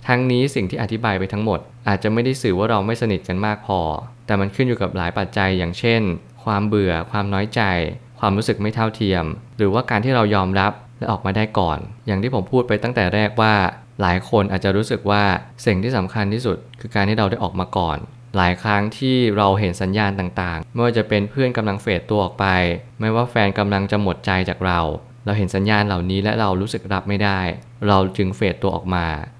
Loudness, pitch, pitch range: -20 LUFS, 100 Hz, 95-115 Hz